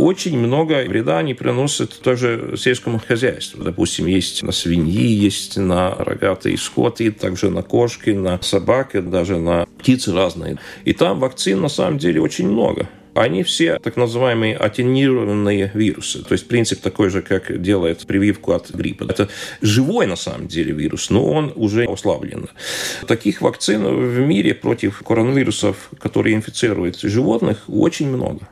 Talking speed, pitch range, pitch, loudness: 145 wpm, 95-125 Hz, 110 Hz, -18 LUFS